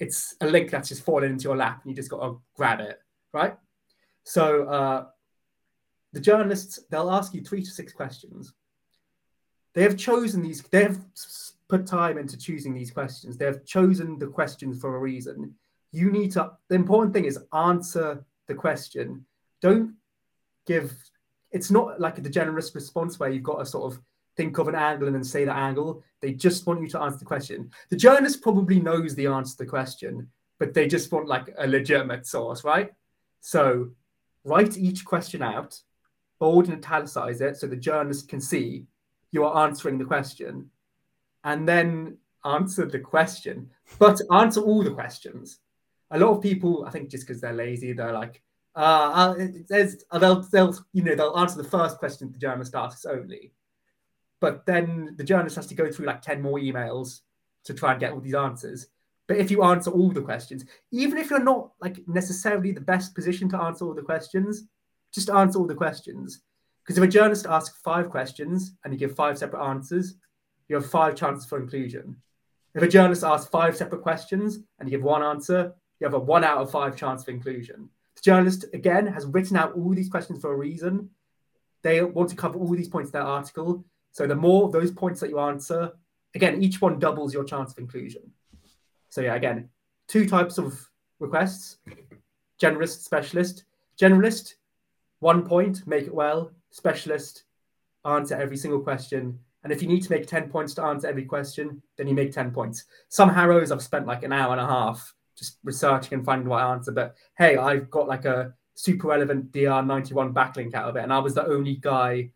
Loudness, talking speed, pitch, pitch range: -24 LUFS, 190 wpm, 155 Hz, 135-180 Hz